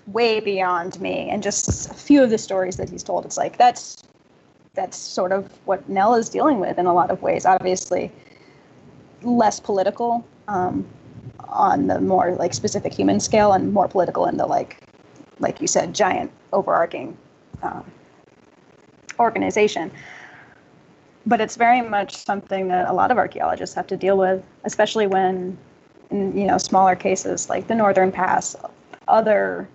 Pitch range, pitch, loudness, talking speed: 185-220 Hz, 195 Hz, -20 LUFS, 160 wpm